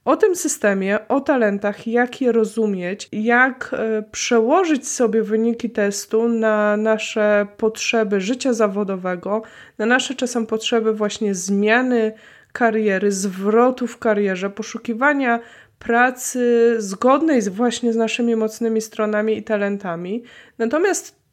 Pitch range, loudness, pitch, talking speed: 210-240 Hz, -19 LUFS, 225 Hz, 115 wpm